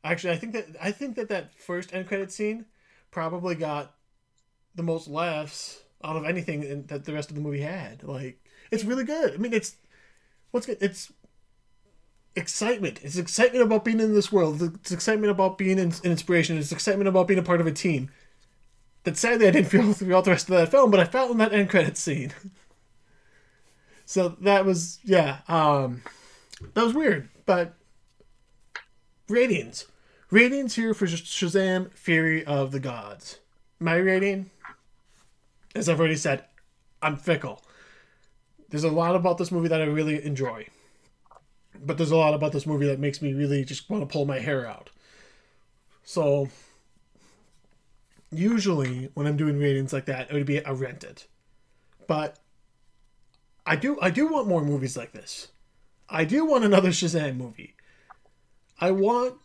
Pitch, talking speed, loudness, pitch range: 170 Hz, 170 wpm, -25 LUFS, 145-195 Hz